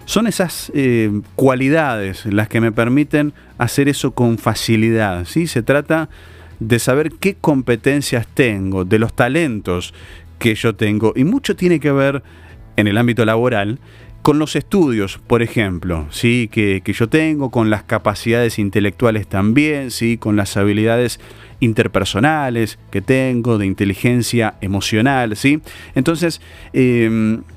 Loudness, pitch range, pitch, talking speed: -16 LUFS, 105-135 Hz, 115 Hz, 135 wpm